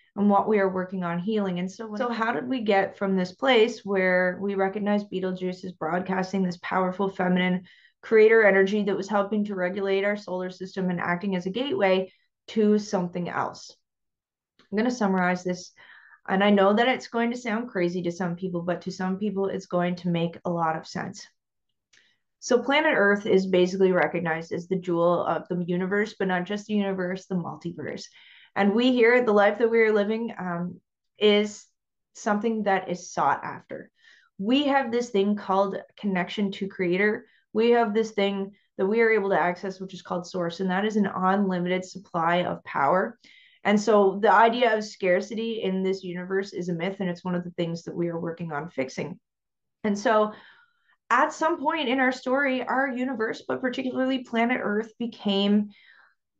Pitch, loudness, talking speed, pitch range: 195 Hz, -25 LUFS, 190 wpm, 180-220 Hz